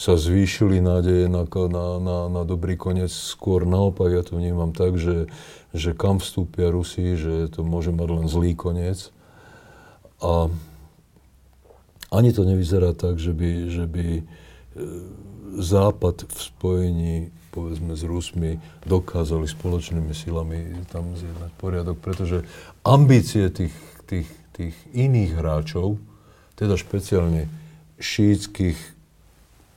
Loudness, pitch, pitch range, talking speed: -23 LUFS, 85 Hz, 85-95 Hz, 120 wpm